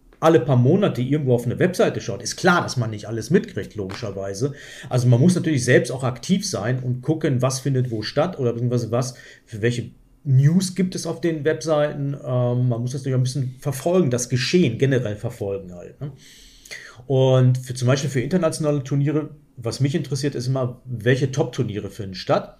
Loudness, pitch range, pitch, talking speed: -21 LUFS, 120-150 Hz, 130 Hz, 185 wpm